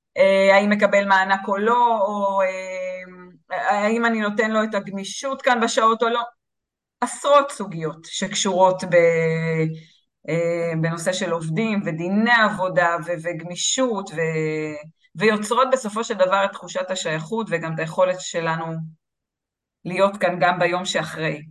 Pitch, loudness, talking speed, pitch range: 185 Hz, -21 LUFS, 115 wpm, 170-215 Hz